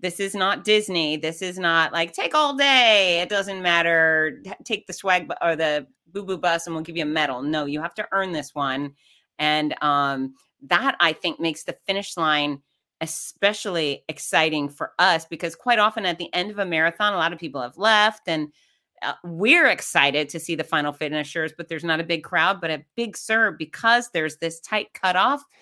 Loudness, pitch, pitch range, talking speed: -22 LUFS, 170 Hz, 155-195 Hz, 205 wpm